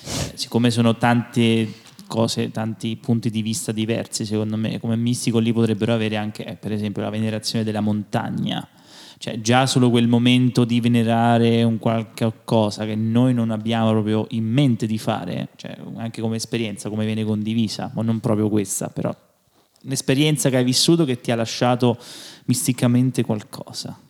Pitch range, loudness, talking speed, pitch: 110-120 Hz, -21 LUFS, 160 wpm, 115 Hz